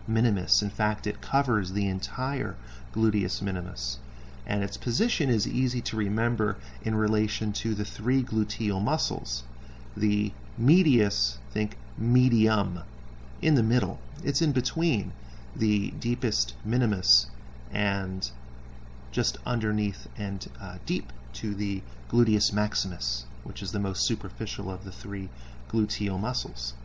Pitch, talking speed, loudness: 105 Hz, 125 wpm, -28 LUFS